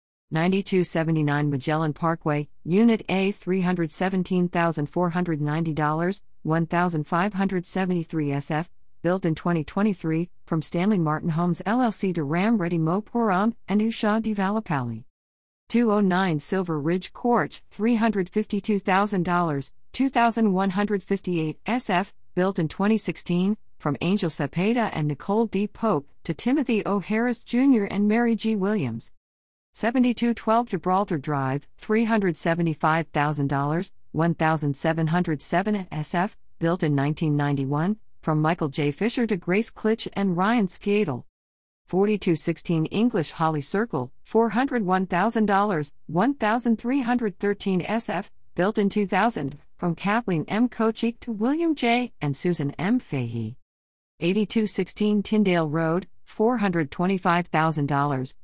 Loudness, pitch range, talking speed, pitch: -24 LUFS, 155-210 Hz, 95 wpm, 180 Hz